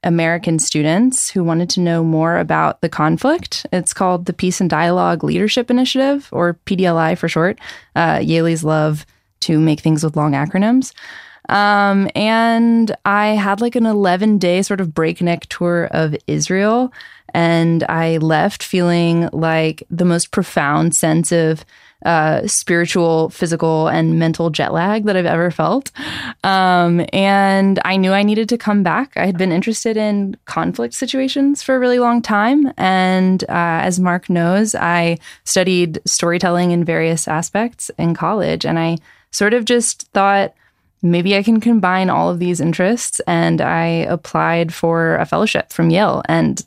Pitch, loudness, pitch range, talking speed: 180 Hz, -16 LUFS, 165-205 Hz, 160 wpm